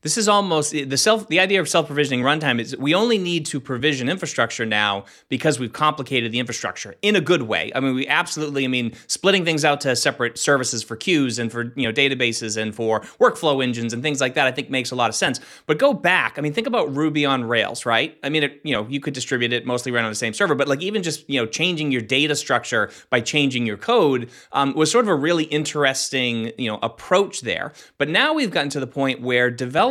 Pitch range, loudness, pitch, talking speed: 120-155 Hz, -20 LUFS, 135 Hz, 245 wpm